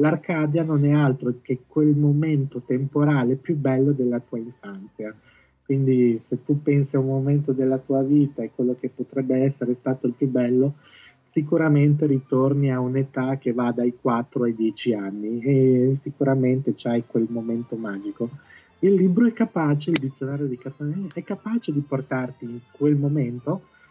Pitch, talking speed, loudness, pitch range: 135 Hz, 160 wpm, -23 LUFS, 125-145 Hz